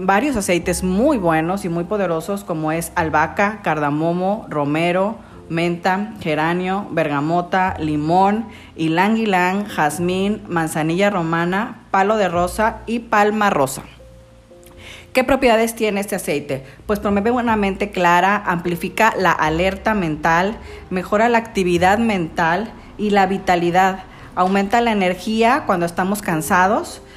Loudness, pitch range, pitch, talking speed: -18 LUFS, 170-205 Hz, 185 Hz, 120 wpm